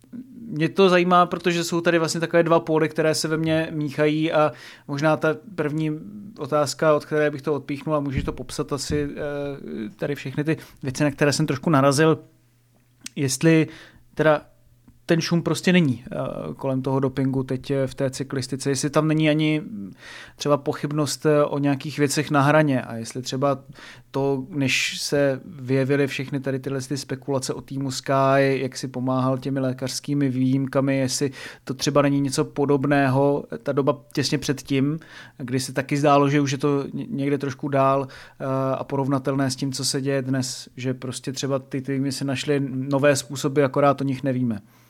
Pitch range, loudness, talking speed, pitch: 135-150 Hz, -23 LUFS, 170 wpm, 140 Hz